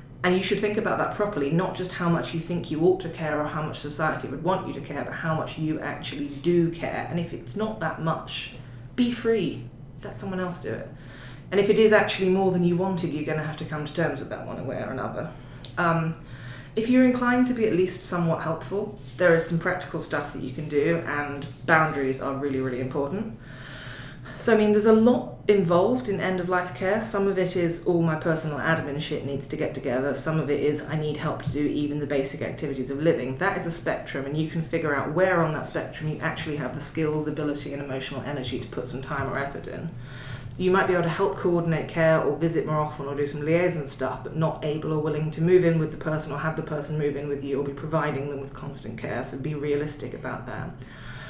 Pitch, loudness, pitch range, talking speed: 155 Hz, -26 LUFS, 140-170 Hz, 245 wpm